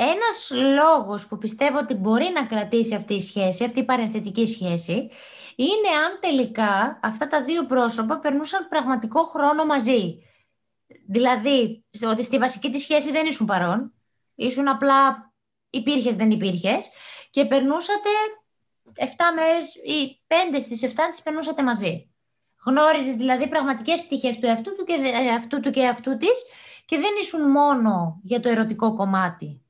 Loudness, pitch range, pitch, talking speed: -22 LUFS, 225-305 Hz, 260 Hz, 145 wpm